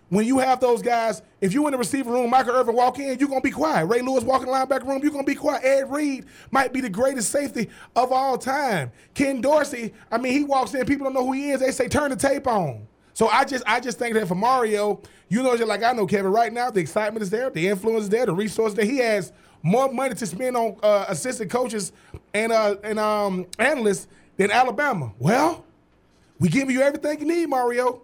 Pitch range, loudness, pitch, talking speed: 210-265 Hz, -22 LUFS, 245 Hz, 240 wpm